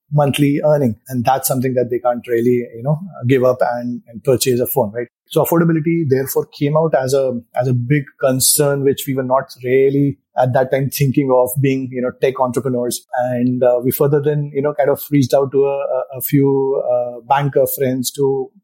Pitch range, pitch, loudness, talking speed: 125-145 Hz, 135 Hz, -16 LUFS, 205 wpm